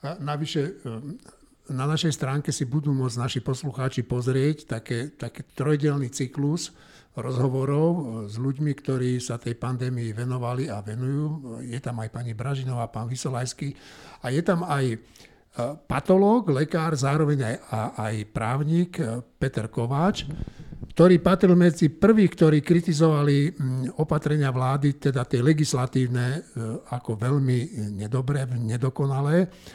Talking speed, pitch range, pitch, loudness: 120 wpm, 125-150 Hz, 135 Hz, -25 LUFS